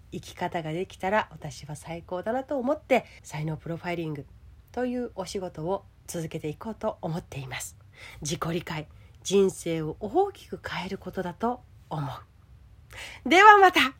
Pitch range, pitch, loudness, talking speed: 150-215 Hz, 170 Hz, -26 LUFS, 305 characters per minute